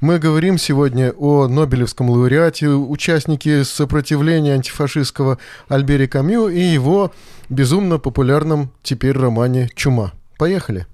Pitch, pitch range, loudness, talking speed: 145 Hz, 130-155 Hz, -16 LUFS, 105 wpm